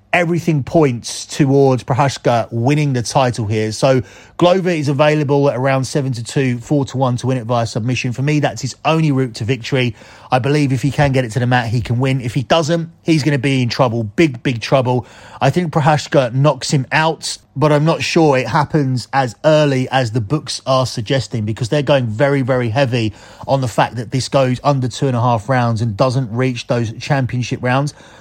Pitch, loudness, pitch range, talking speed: 135 Hz, -16 LUFS, 125-145 Hz, 215 wpm